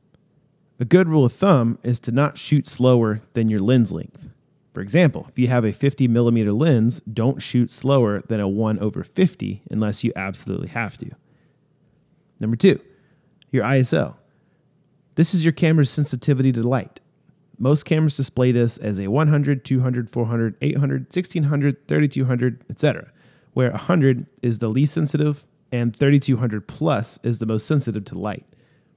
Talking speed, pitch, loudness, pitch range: 155 wpm, 135 Hz, -20 LUFS, 120-155 Hz